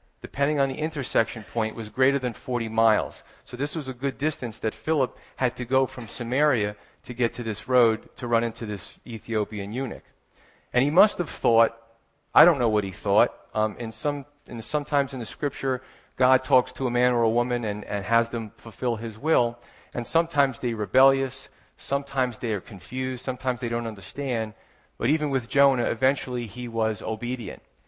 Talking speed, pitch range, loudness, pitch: 190 wpm, 115-135 Hz, -25 LUFS, 120 Hz